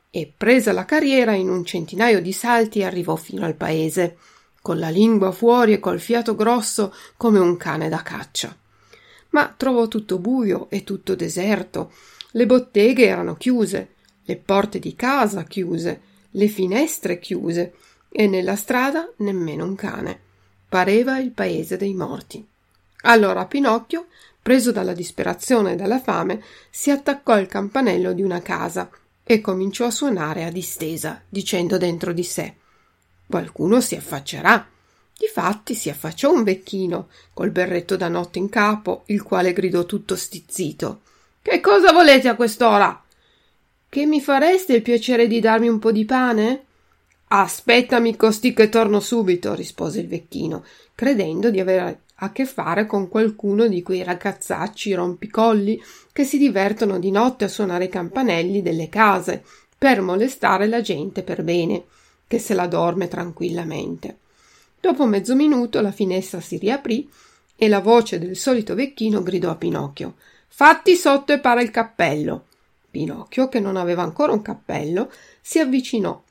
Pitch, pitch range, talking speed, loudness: 210 Hz, 185-240 Hz, 150 wpm, -19 LUFS